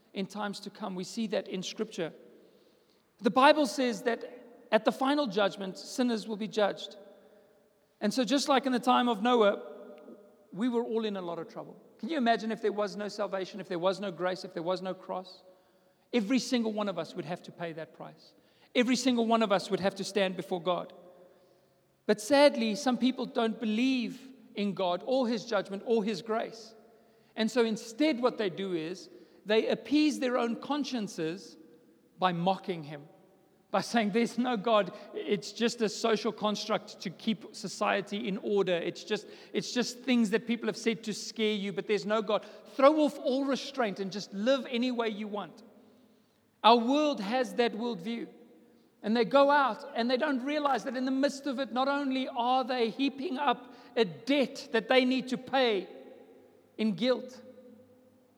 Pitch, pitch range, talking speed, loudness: 220 Hz, 195-250 Hz, 190 wpm, -30 LUFS